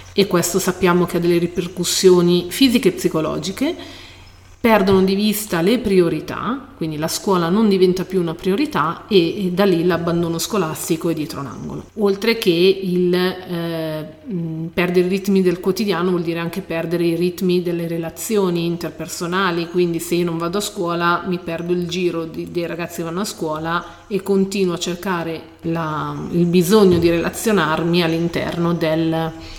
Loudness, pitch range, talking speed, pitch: -19 LUFS, 170-190 Hz, 160 wpm, 175 Hz